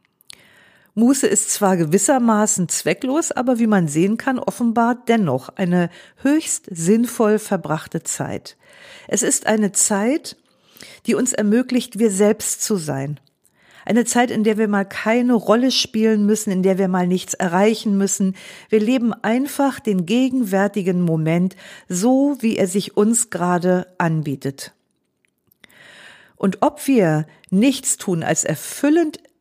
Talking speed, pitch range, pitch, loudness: 135 wpm, 185-235 Hz, 210 Hz, -18 LUFS